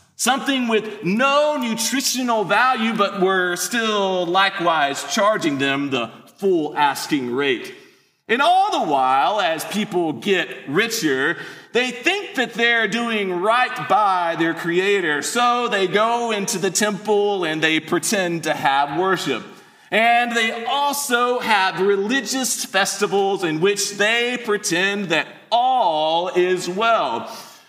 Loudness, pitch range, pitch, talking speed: -19 LUFS, 180-240 Hz, 210 Hz, 125 wpm